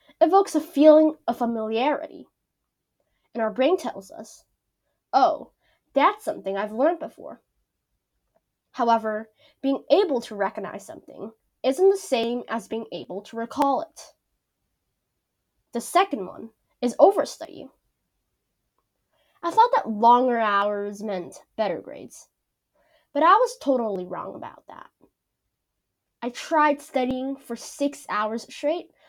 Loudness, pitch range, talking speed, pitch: -23 LUFS, 215-305 Hz, 120 wpm, 245 Hz